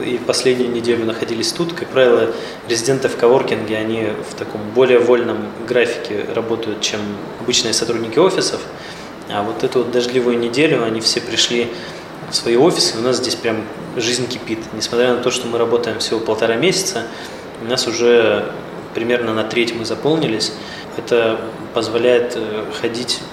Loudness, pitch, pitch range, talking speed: -17 LUFS, 120 Hz, 110-125 Hz, 155 wpm